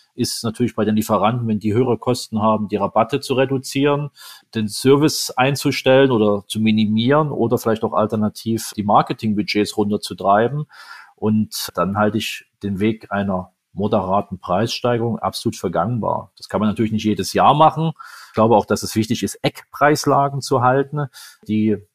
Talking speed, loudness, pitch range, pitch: 155 wpm, -19 LUFS, 105-130 Hz, 110 Hz